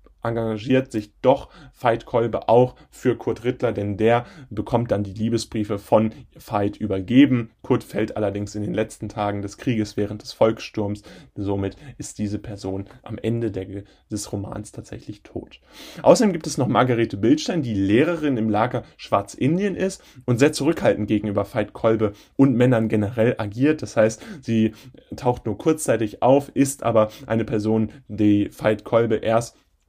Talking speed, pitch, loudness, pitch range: 155 wpm, 110 Hz, -22 LUFS, 105-130 Hz